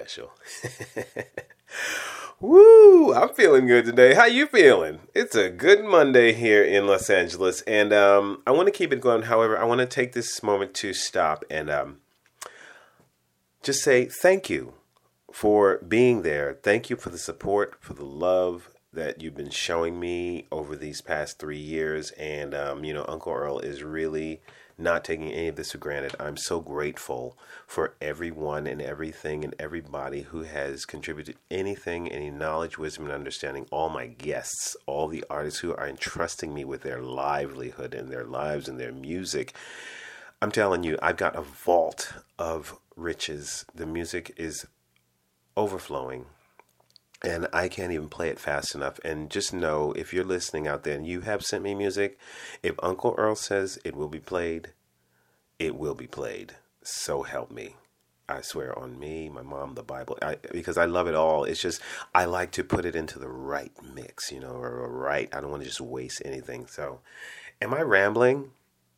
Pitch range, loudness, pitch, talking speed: 75-110 Hz, -24 LUFS, 85 Hz, 175 wpm